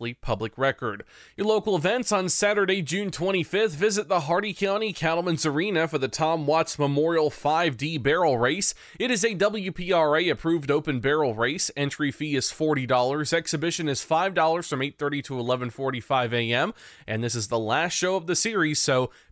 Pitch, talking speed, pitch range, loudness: 160 Hz, 165 wpm, 135-185 Hz, -24 LUFS